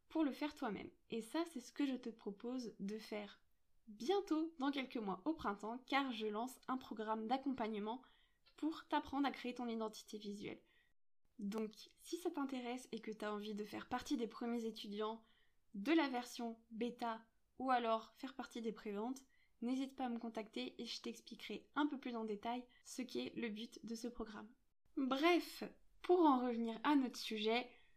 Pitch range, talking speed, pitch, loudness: 220-270 Hz, 180 wpm, 240 Hz, -43 LUFS